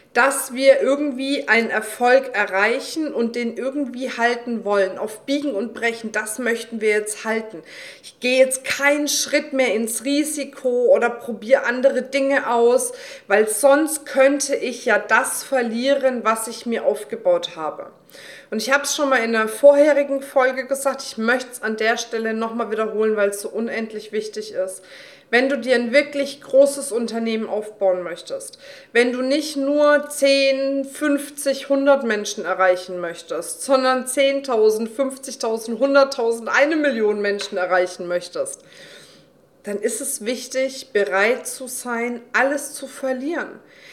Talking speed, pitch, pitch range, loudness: 150 wpm, 250 Hz, 220-275 Hz, -20 LUFS